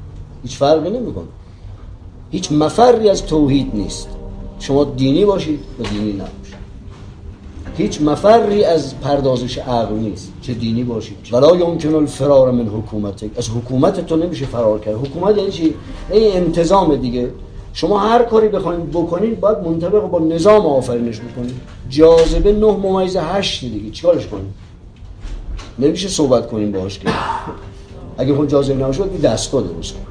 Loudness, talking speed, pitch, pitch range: -16 LUFS, 140 wpm, 130 Hz, 100-170 Hz